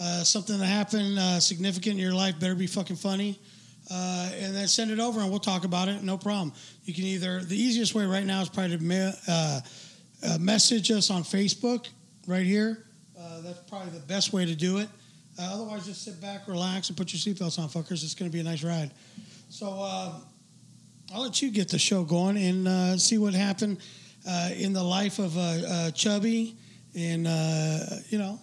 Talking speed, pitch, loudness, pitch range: 210 wpm, 190 Hz, -27 LUFS, 175-200 Hz